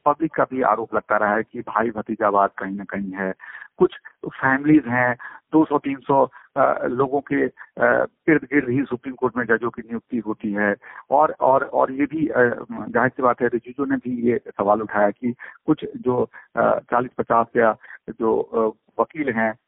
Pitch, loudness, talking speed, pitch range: 120 Hz, -21 LUFS, 170 wpm, 110-140 Hz